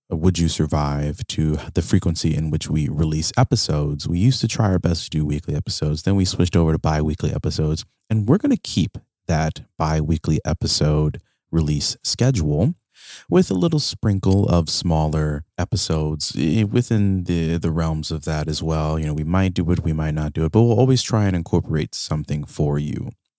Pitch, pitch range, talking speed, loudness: 80 Hz, 75-100 Hz, 190 wpm, -21 LUFS